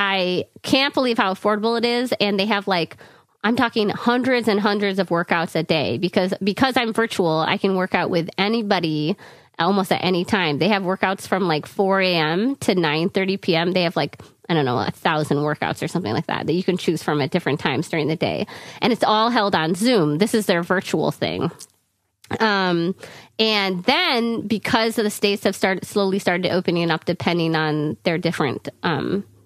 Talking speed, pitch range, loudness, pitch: 200 wpm, 170-210 Hz, -20 LUFS, 190 Hz